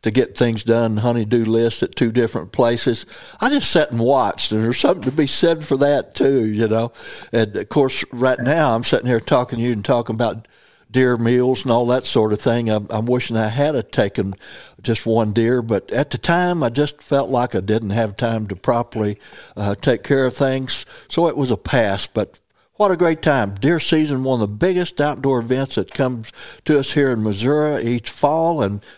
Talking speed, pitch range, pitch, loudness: 215 wpm, 115-140 Hz, 125 Hz, -19 LUFS